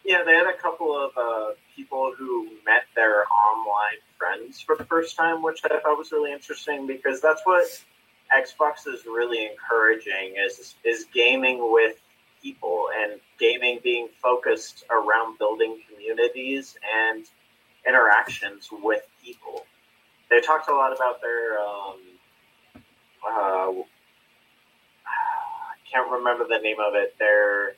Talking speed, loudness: 135 wpm, -23 LUFS